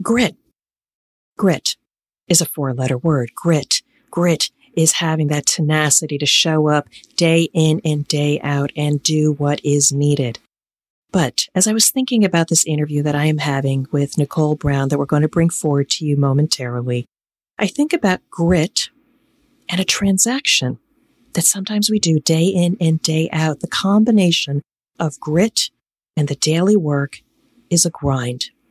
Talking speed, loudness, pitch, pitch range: 160 wpm, -17 LUFS, 155 Hz, 145-180 Hz